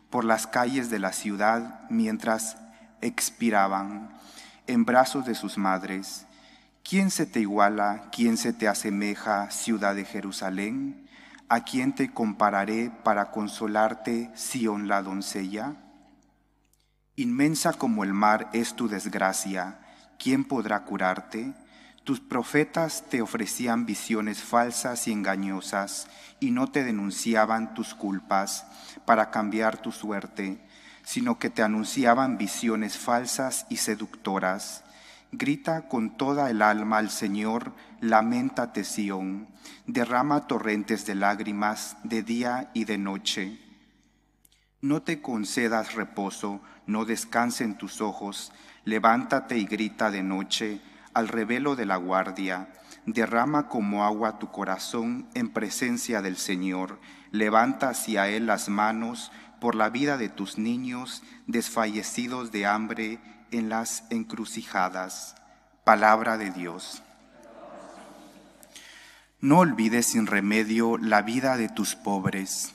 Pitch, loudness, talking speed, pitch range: 110 Hz, -27 LUFS, 120 wpm, 100-120 Hz